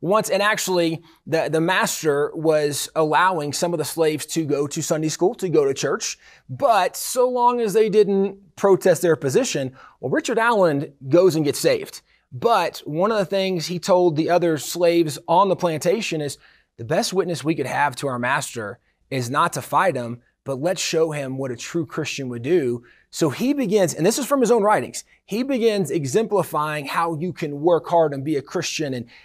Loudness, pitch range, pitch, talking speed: -21 LUFS, 145-195 Hz, 165 Hz, 200 wpm